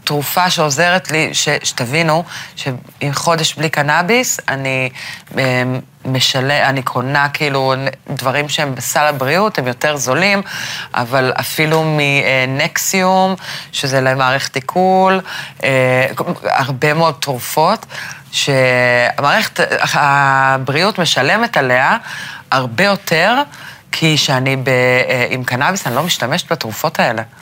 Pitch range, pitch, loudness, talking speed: 130-165 Hz, 145 Hz, -14 LUFS, 105 wpm